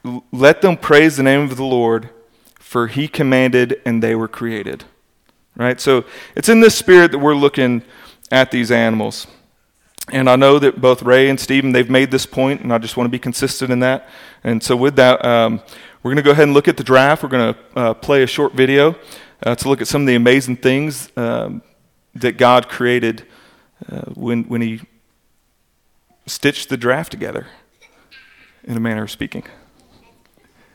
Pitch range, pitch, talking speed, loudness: 120-140 Hz, 130 Hz, 190 wpm, -14 LUFS